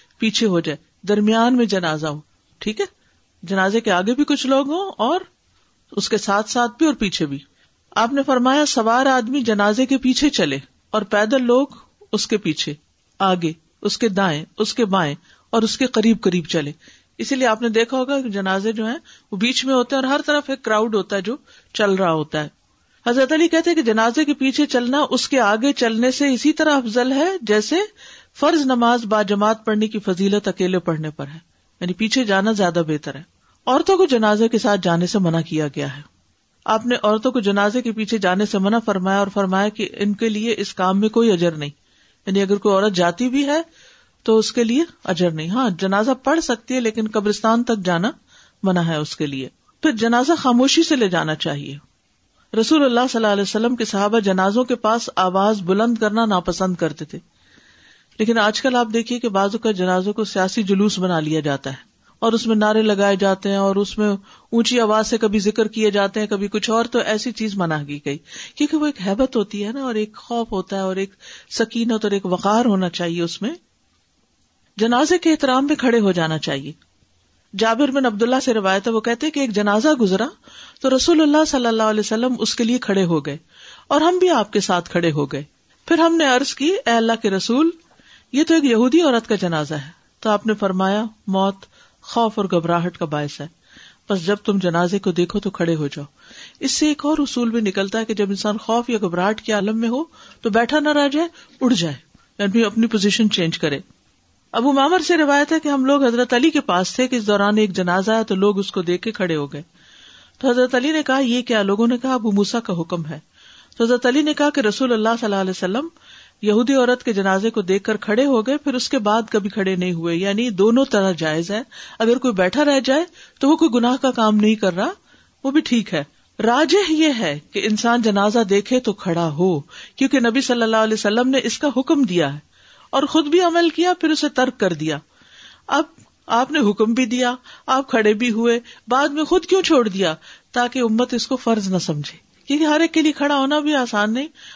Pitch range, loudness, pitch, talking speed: 195-255 Hz, -19 LUFS, 220 Hz, 220 wpm